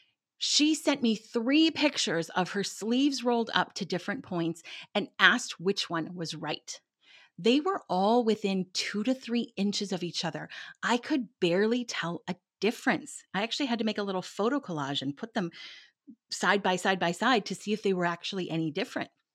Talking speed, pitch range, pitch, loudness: 190 wpm, 175-235 Hz, 200 Hz, -29 LUFS